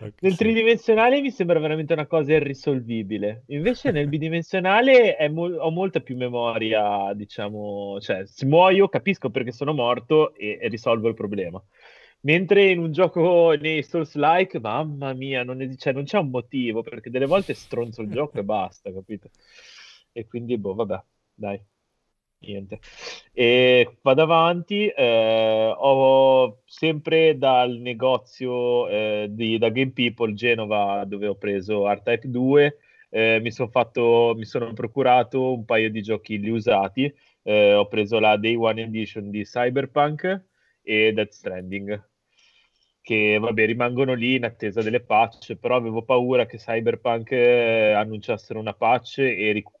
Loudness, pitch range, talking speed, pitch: -21 LUFS, 110-150 Hz, 145 wpm, 125 Hz